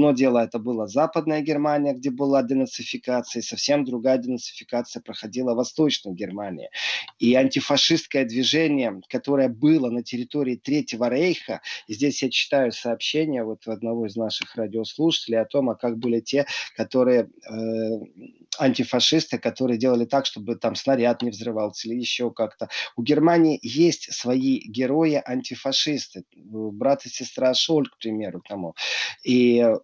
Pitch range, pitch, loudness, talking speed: 115-140 Hz, 125 Hz, -23 LUFS, 140 wpm